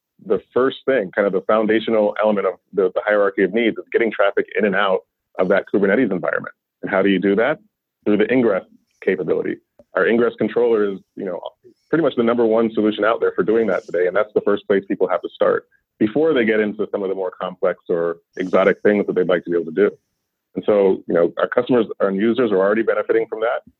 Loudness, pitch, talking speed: -19 LUFS, 120 Hz, 235 wpm